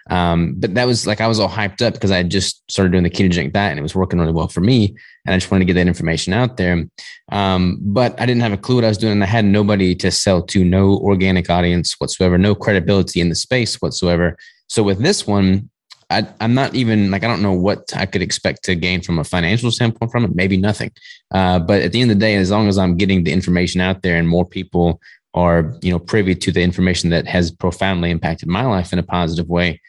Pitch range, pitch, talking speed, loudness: 90-105 Hz, 95 Hz, 255 wpm, -16 LUFS